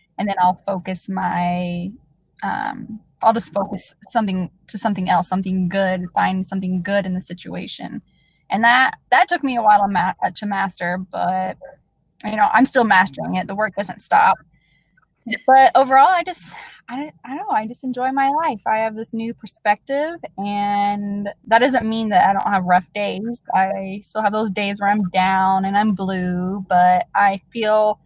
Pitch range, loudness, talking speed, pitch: 185-230 Hz, -19 LUFS, 180 wpm, 205 Hz